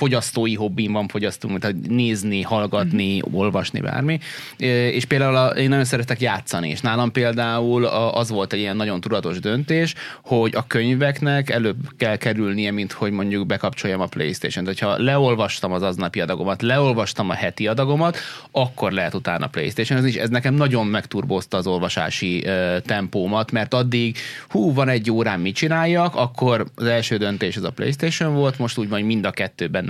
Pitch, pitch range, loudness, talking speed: 115 Hz, 100-130 Hz, -21 LUFS, 165 wpm